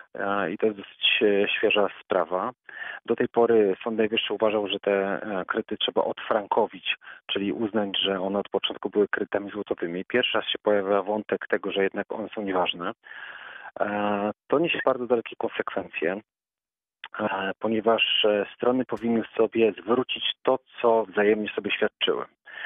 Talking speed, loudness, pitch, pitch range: 135 wpm, -25 LUFS, 105 Hz, 100-115 Hz